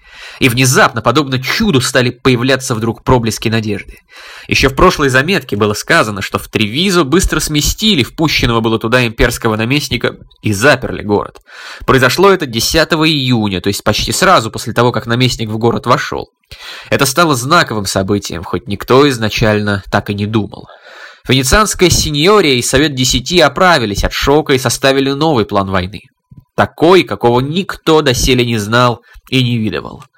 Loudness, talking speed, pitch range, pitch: -12 LUFS, 155 wpm, 110-145 Hz, 125 Hz